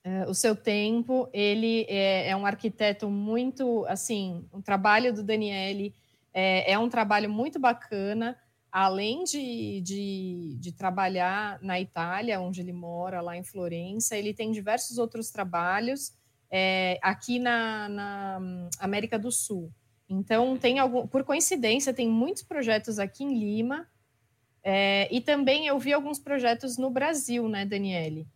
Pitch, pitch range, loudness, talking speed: 210 Hz, 190-240 Hz, -28 LUFS, 140 wpm